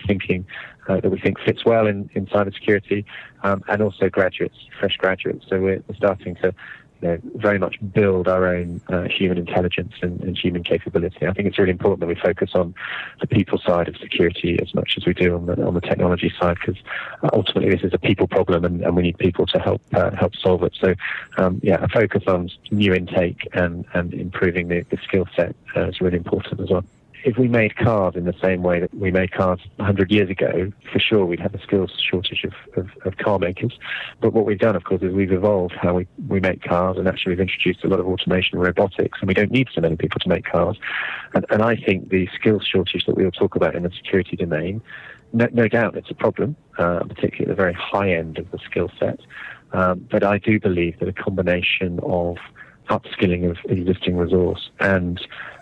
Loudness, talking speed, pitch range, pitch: -21 LUFS, 225 wpm, 90-100 Hz, 95 Hz